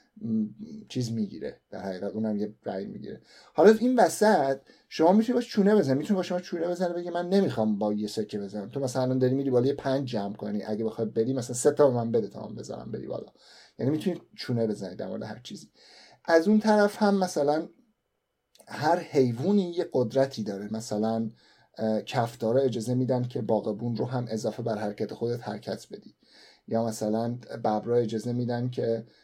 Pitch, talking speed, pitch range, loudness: 125 Hz, 185 wpm, 110-175 Hz, -27 LUFS